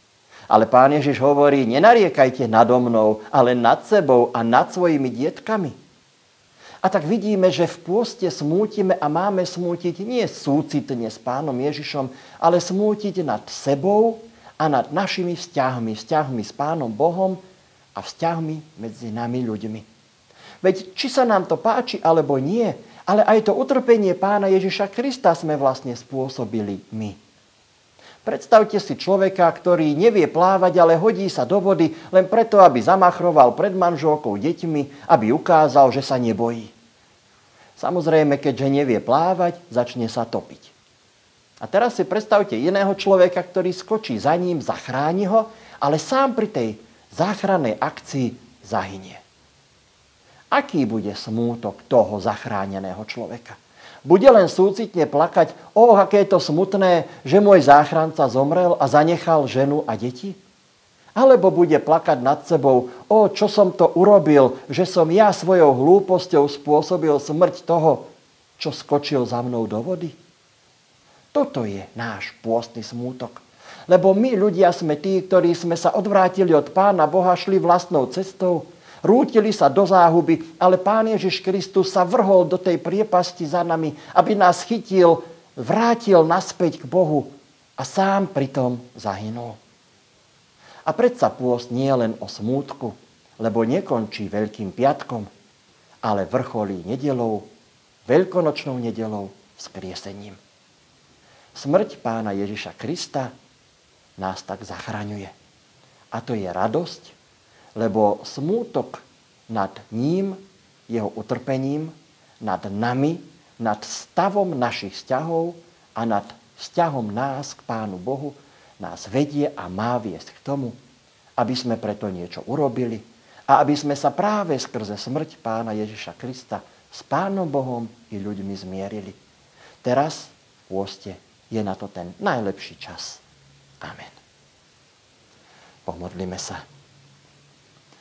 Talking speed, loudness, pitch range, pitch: 130 wpm, -19 LUFS, 115-185 Hz, 150 Hz